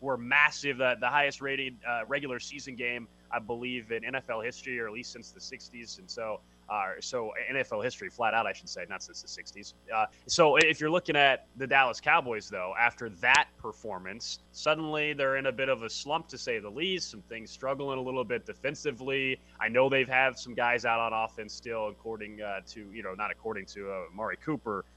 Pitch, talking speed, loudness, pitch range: 130 Hz, 205 wpm, -30 LUFS, 115-140 Hz